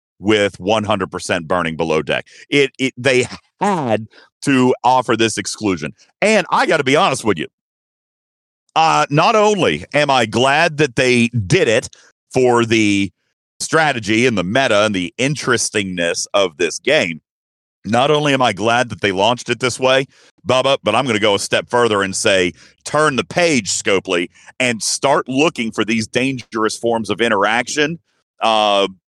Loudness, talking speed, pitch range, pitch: -16 LUFS, 165 wpm, 105-130 Hz, 115 Hz